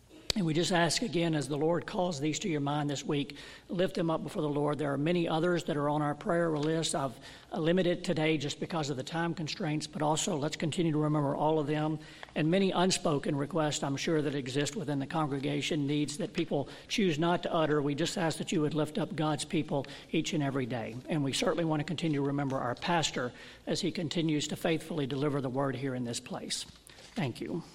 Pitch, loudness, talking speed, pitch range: 155 Hz, -32 LUFS, 225 wpm, 145-170 Hz